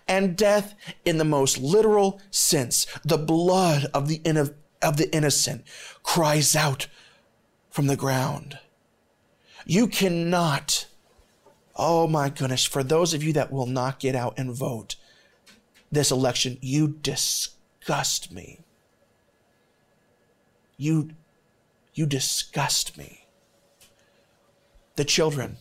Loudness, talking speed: -23 LUFS, 110 wpm